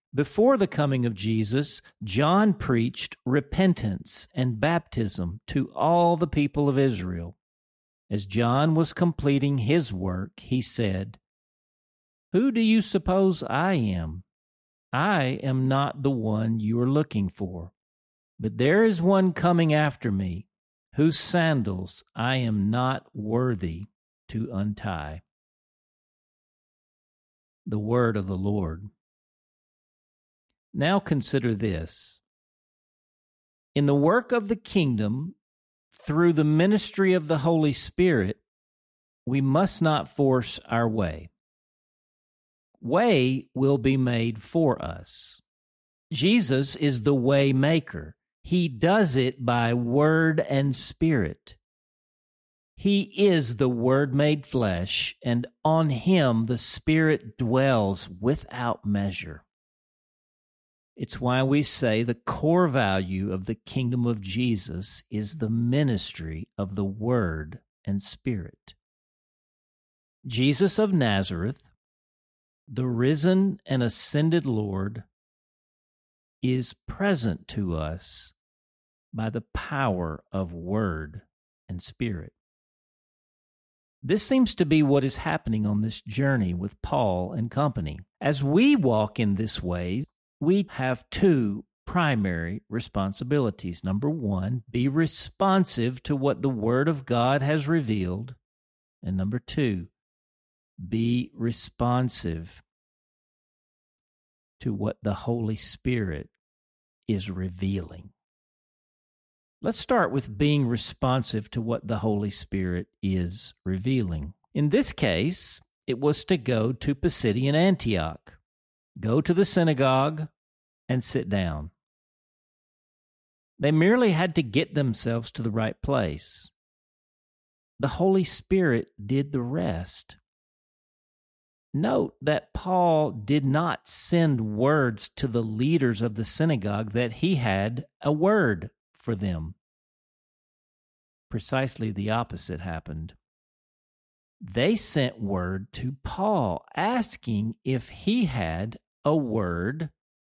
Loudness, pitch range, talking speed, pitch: -25 LUFS, 100-145 Hz, 110 wpm, 120 Hz